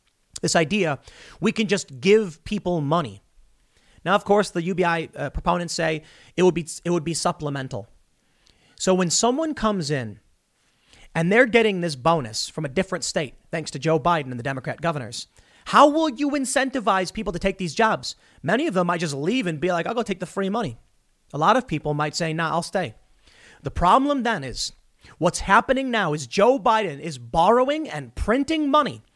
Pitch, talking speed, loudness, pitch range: 175 Hz, 195 wpm, -22 LUFS, 155-215 Hz